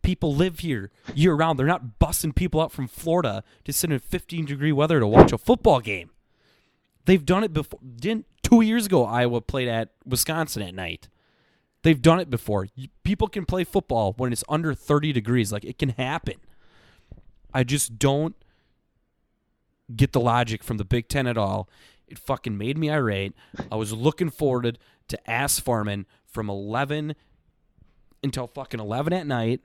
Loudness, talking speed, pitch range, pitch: -24 LUFS, 170 wpm, 115-155 Hz, 135 Hz